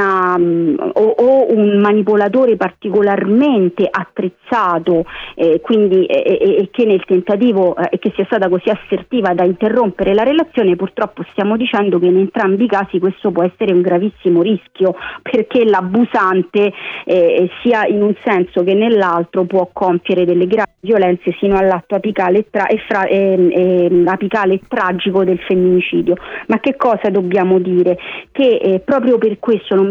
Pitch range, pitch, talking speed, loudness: 185-220 Hz, 195 Hz, 150 wpm, -14 LUFS